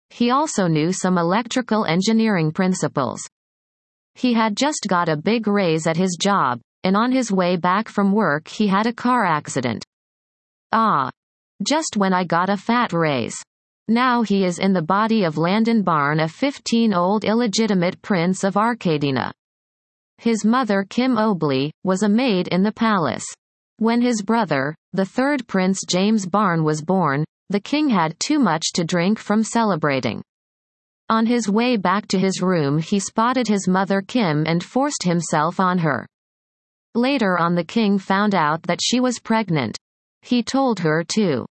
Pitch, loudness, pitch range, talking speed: 195 Hz, -20 LUFS, 170-225 Hz, 160 wpm